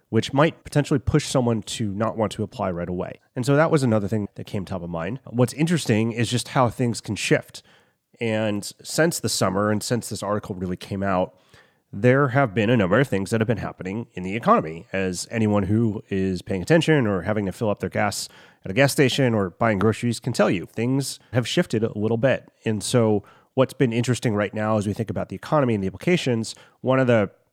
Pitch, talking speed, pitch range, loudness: 115 Hz, 225 wpm, 105-125 Hz, -23 LUFS